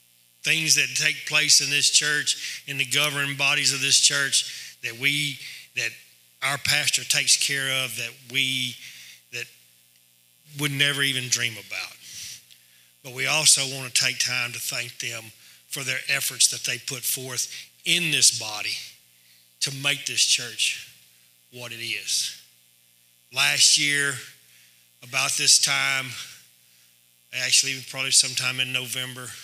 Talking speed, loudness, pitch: 135 wpm, -21 LUFS, 125 Hz